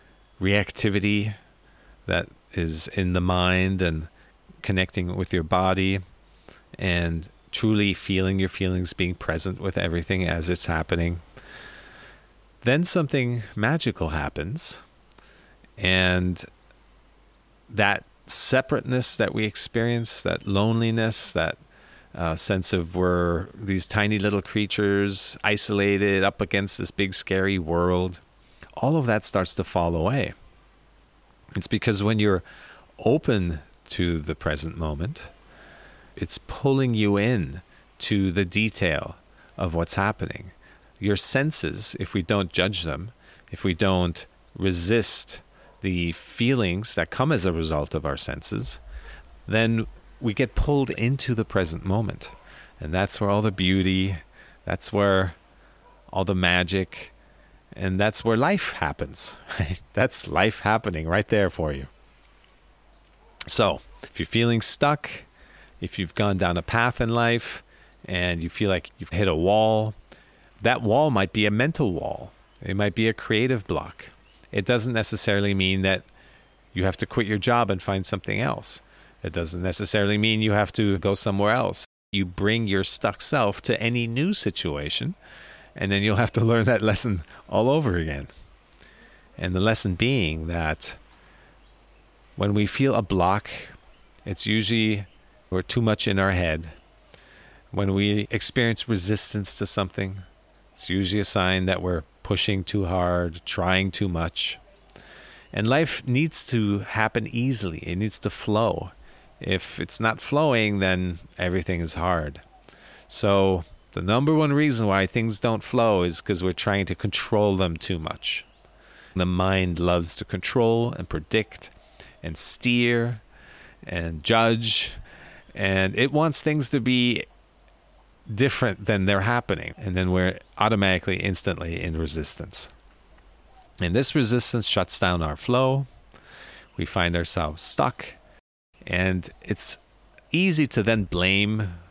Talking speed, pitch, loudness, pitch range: 135 wpm, 100 Hz, -24 LUFS, 90-110 Hz